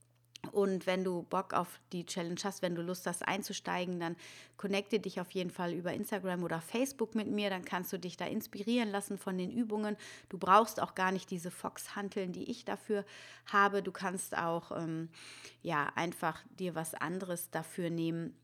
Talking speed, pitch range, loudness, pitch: 185 wpm, 175-205 Hz, -36 LUFS, 185 Hz